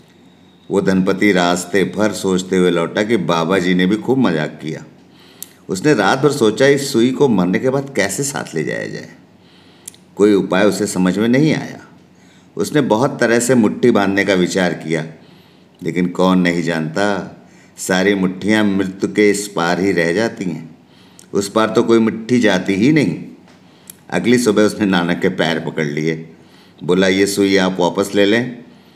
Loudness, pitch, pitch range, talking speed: -16 LUFS, 100 Hz, 90-110 Hz, 170 wpm